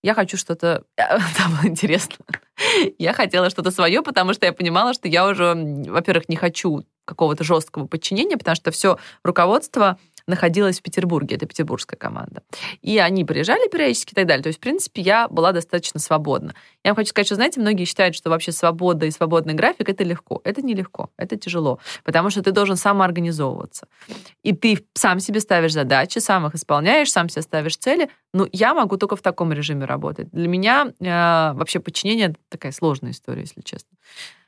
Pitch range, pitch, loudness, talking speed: 165-200 Hz, 180 Hz, -19 LUFS, 180 wpm